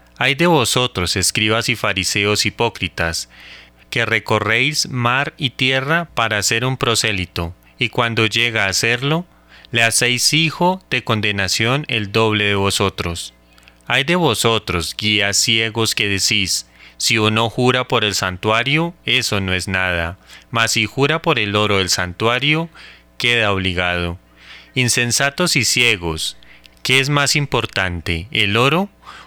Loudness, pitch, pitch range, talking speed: -16 LUFS, 110 Hz, 95-125 Hz, 135 wpm